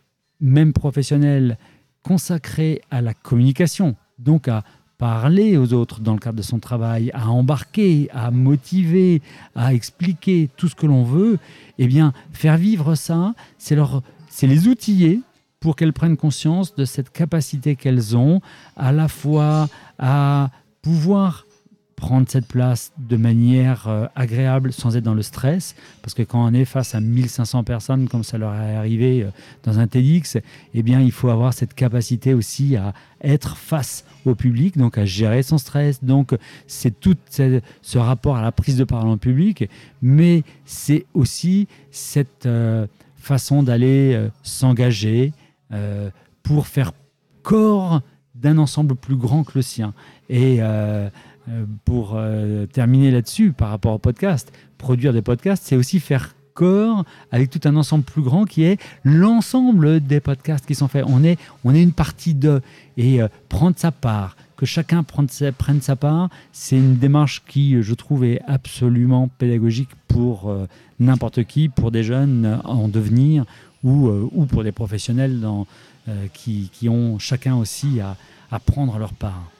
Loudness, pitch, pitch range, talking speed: -18 LUFS, 135 Hz, 120-150 Hz, 165 wpm